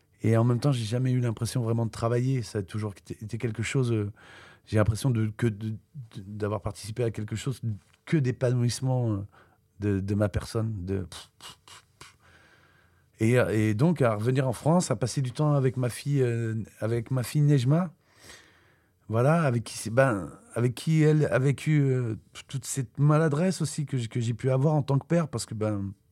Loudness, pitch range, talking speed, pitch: -27 LUFS, 110-135 Hz, 180 wpm, 120 Hz